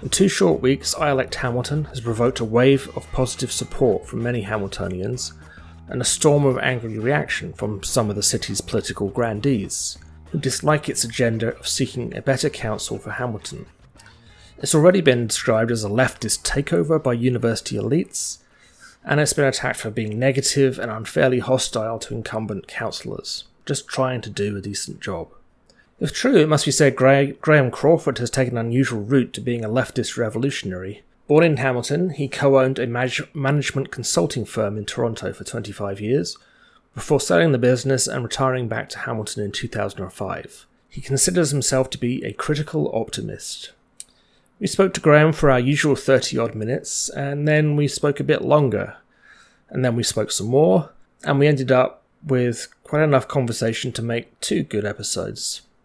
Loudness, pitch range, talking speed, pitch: -21 LUFS, 110-140 Hz, 175 wpm, 130 Hz